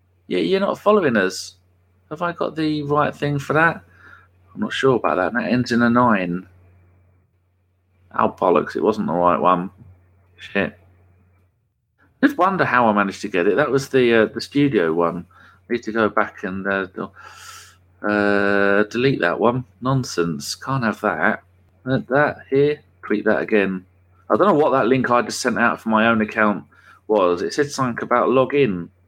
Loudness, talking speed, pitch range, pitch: -19 LUFS, 180 wpm, 90-125 Hz, 105 Hz